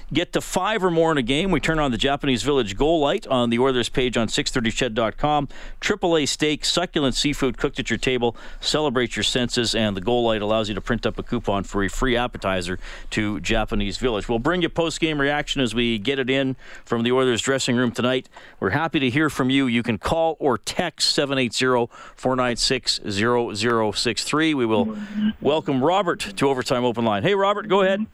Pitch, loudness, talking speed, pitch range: 130 Hz, -22 LUFS, 205 wpm, 115-145 Hz